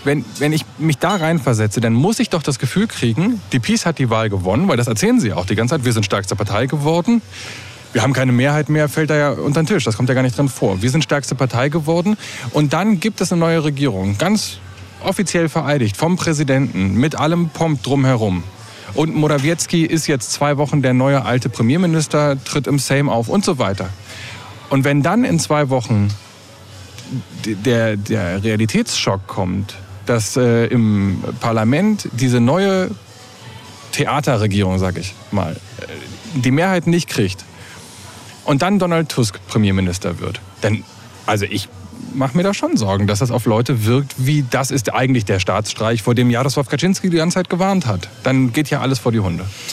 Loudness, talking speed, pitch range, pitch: -17 LUFS, 185 wpm, 110-150 Hz, 130 Hz